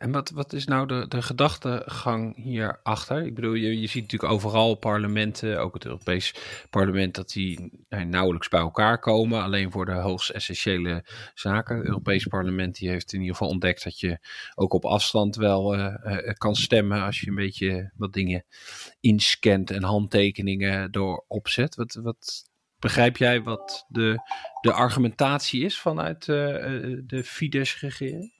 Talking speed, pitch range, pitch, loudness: 165 wpm, 95-120 Hz, 110 Hz, -25 LUFS